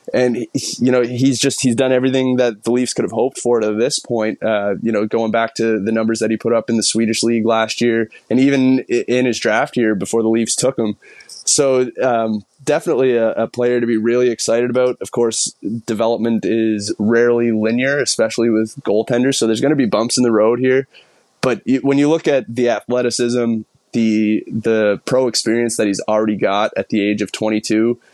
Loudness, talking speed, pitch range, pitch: -16 LUFS, 205 wpm, 110-125 Hz, 115 Hz